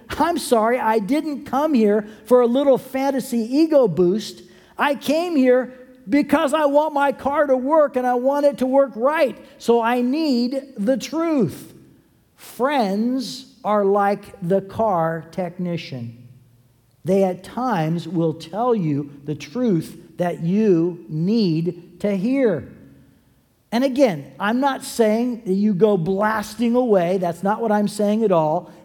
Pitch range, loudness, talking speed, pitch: 180-265 Hz, -20 LUFS, 145 wpm, 220 Hz